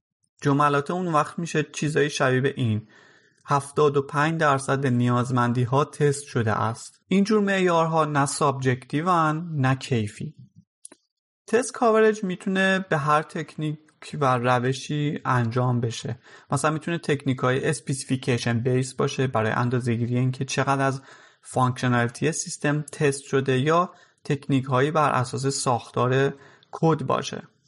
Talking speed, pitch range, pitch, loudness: 120 wpm, 130-155 Hz, 140 Hz, -24 LUFS